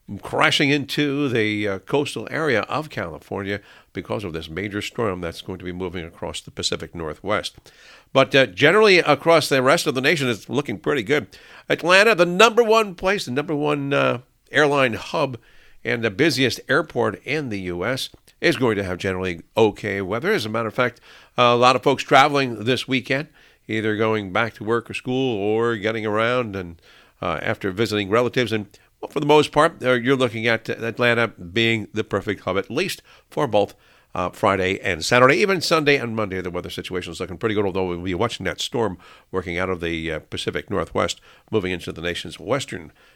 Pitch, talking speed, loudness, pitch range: 115 Hz, 185 wpm, -21 LUFS, 95-135 Hz